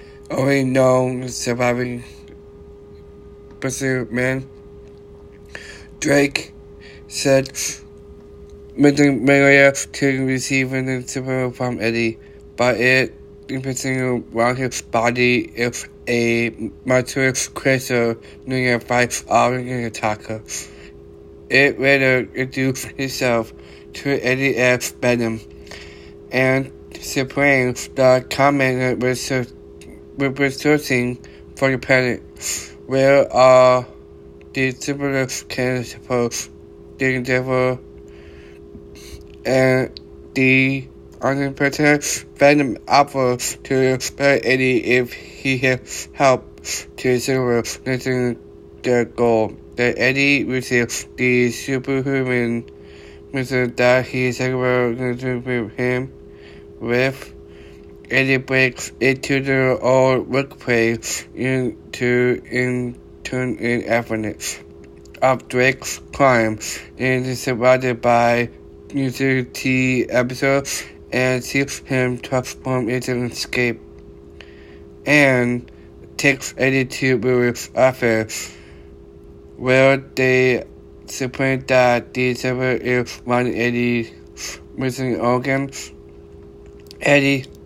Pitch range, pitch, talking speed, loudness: 80-130 Hz, 125 Hz, 90 wpm, -18 LUFS